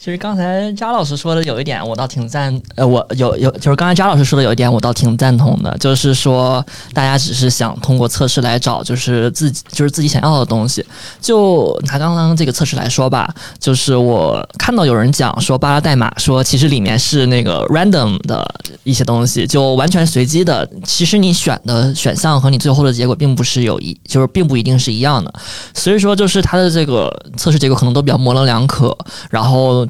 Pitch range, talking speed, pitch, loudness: 125-155 Hz, 340 characters per minute, 135 Hz, -13 LUFS